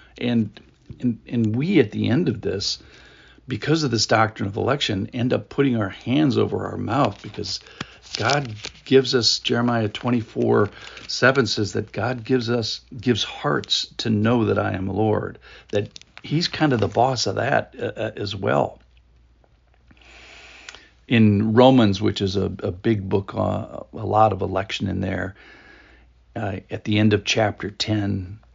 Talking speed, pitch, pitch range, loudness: 160 wpm, 110 Hz, 100-120 Hz, -22 LUFS